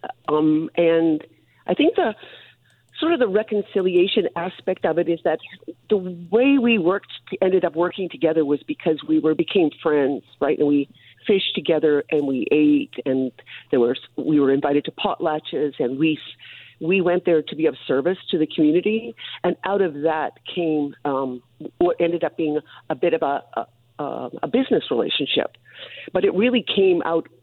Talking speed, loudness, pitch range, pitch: 175 wpm, -21 LUFS, 150-185 Hz, 165 Hz